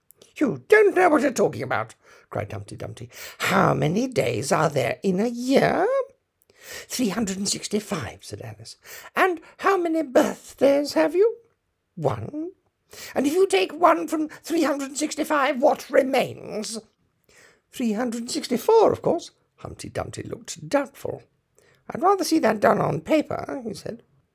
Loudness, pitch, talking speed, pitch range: -23 LUFS, 310 Hz, 160 wpm, 240-380 Hz